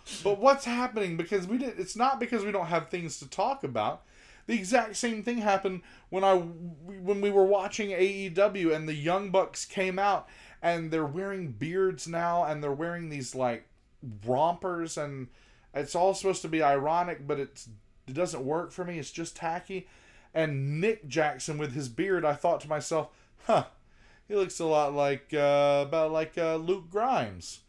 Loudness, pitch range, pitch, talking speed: -29 LUFS, 150-195 Hz, 170 Hz, 180 wpm